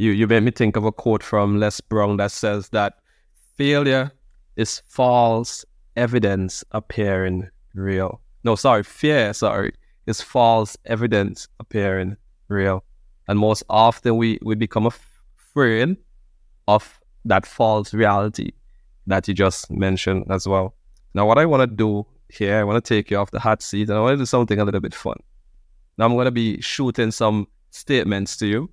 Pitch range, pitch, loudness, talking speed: 95-115 Hz, 105 Hz, -20 LUFS, 170 wpm